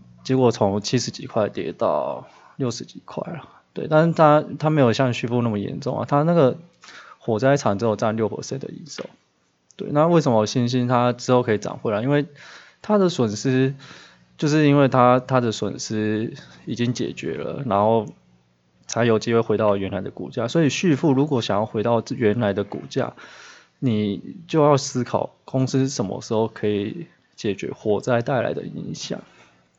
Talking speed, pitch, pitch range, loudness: 260 characters per minute, 120 Hz, 105-135 Hz, -21 LUFS